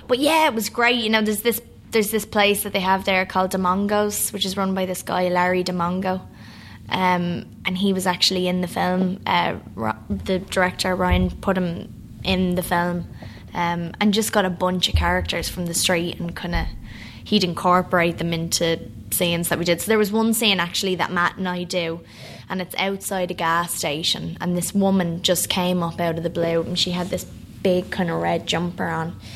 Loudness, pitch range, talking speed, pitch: -21 LUFS, 170-190 Hz, 210 wpm, 180 Hz